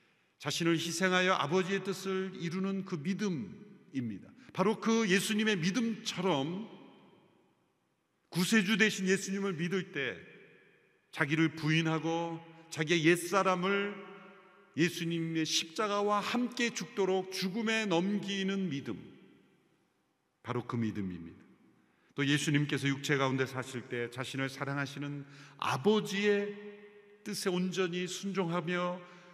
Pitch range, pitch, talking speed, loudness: 155-195 Hz, 185 Hz, 250 characters per minute, -32 LUFS